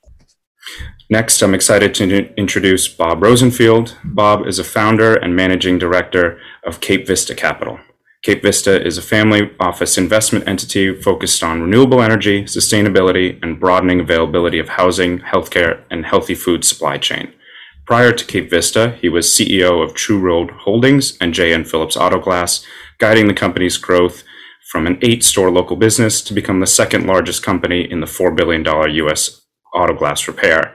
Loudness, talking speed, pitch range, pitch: -13 LUFS, 155 wpm, 90-110 Hz, 95 Hz